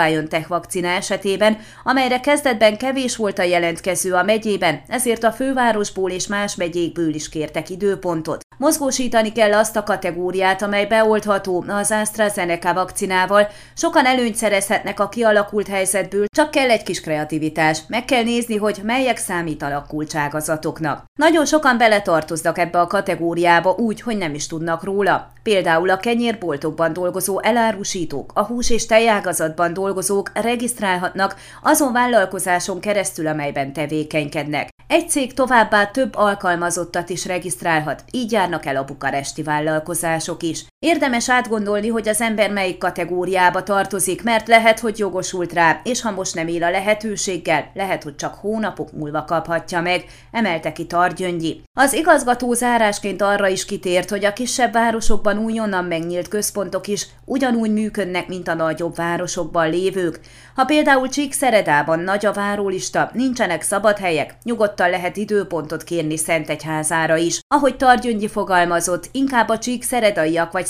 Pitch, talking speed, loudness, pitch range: 195 Hz, 135 wpm, -19 LUFS, 170-220 Hz